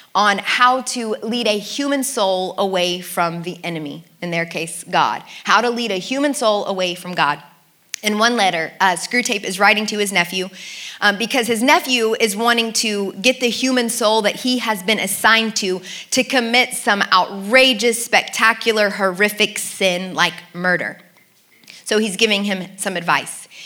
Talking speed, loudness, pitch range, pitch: 165 wpm, -17 LUFS, 185-235 Hz, 210 Hz